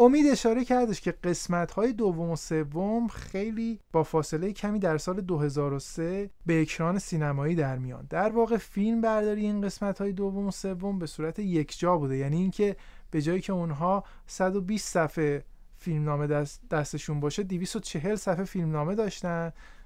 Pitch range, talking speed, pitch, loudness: 160-205 Hz, 155 wpm, 180 Hz, -29 LUFS